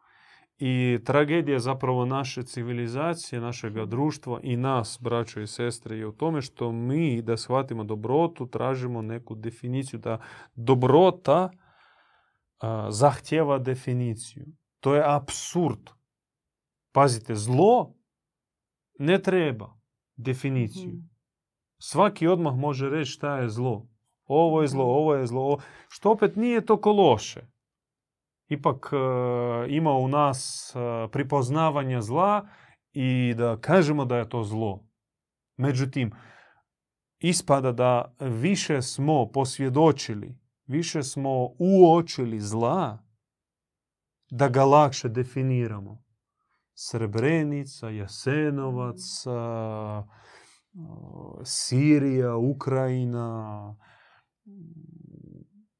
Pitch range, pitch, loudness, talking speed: 120-150 Hz, 130 Hz, -25 LUFS, 95 wpm